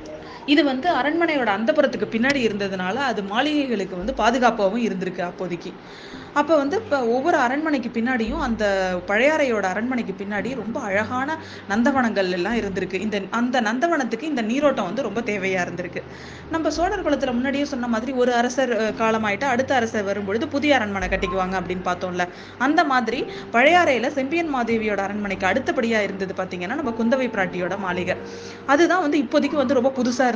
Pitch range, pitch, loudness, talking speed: 200-275 Hz, 235 Hz, -22 LUFS, 140 wpm